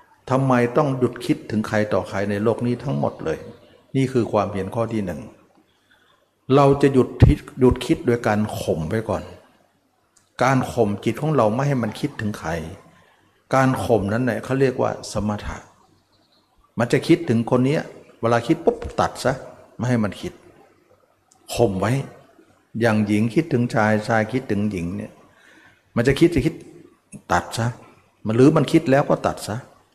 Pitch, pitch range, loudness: 120 Hz, 105-130 Hz, -21 LUFS